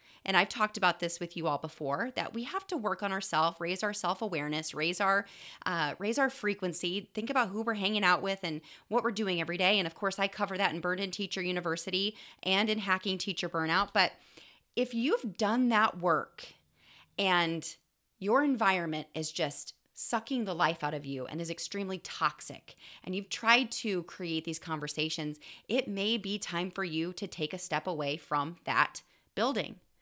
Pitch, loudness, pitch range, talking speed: 185 Hz, -32 LUFS, 165-210 Hz, 190 wpm